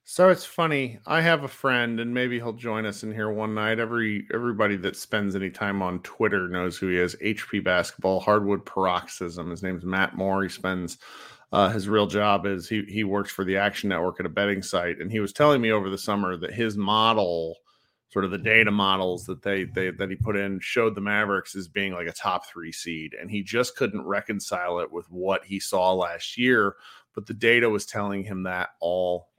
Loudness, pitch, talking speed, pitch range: -25 LUFS, 100 Hz, 220 wpm, 95-110 Hz